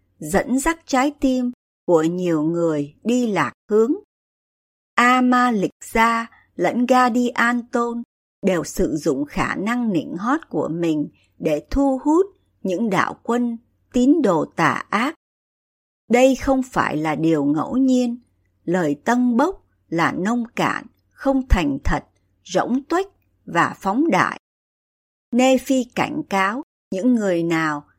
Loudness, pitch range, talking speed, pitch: -20 LUFS, 175-260 Hz, 135 wpm, 240 Hz